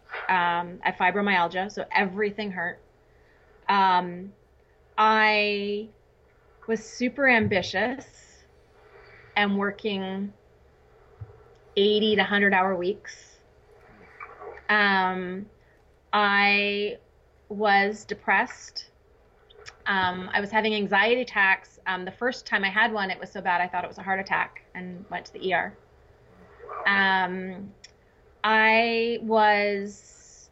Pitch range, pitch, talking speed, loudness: 185-215 Hz, 200 Hz, 105 wpm, -24 LUFS